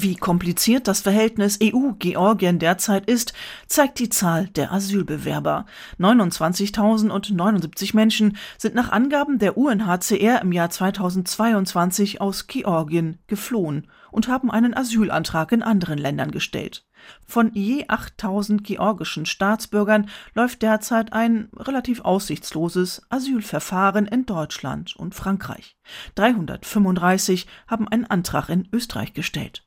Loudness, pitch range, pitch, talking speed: -21 LUFS, 180-225 Hz, 205 Hz, 110 wpm